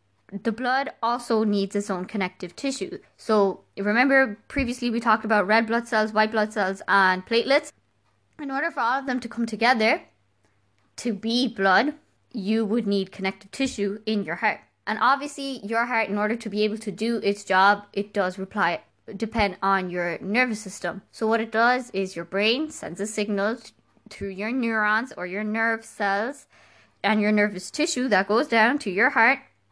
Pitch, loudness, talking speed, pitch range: 215 Hz, -24 LUFS, 180 wpm, 200-235 Hz